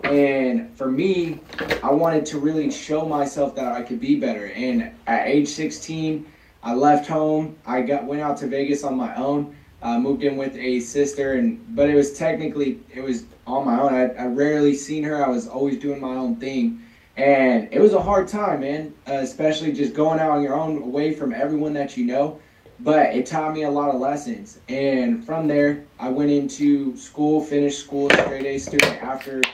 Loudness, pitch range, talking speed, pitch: -22 LUFS, 135-155 Hz, 205 wpm, 145 Hz